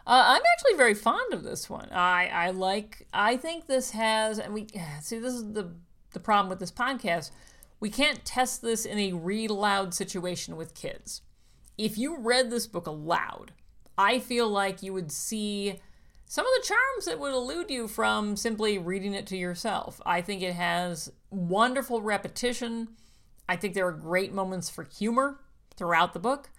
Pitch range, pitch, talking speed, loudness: 180-240 Hz, 205 Hz, 180 wpm, -28 LUFS